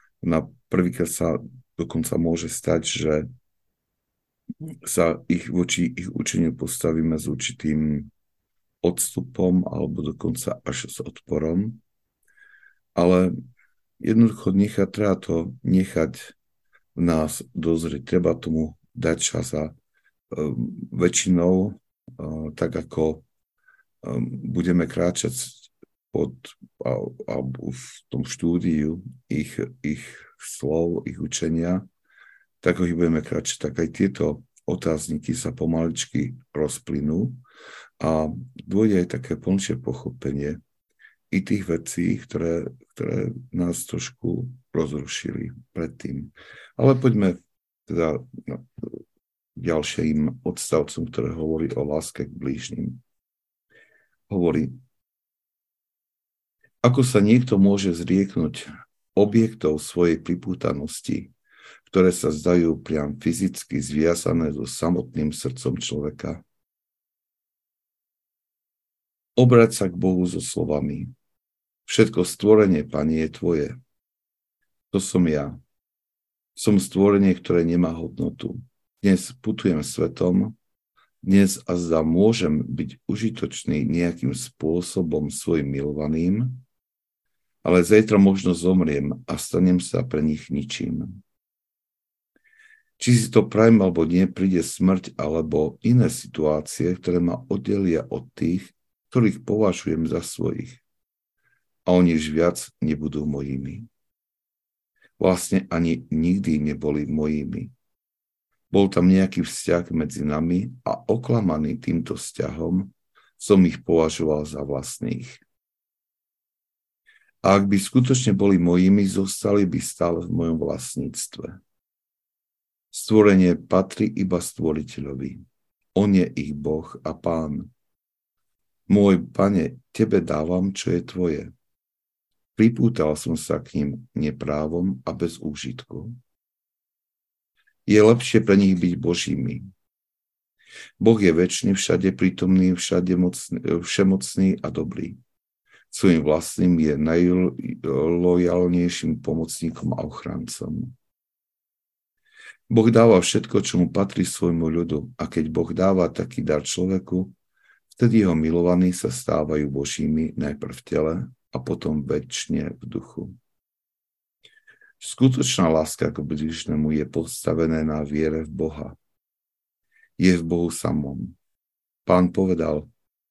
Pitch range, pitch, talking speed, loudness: 80-100 Hz, 90 Hz, 105 wpm, -23 LUFS